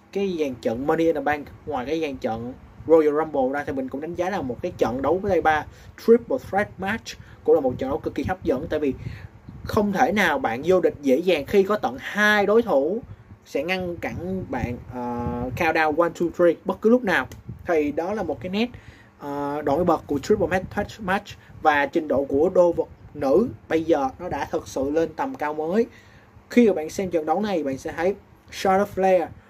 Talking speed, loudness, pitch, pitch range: 225 wpm, -23 LUFS, 165 Hz, 145-195 Hz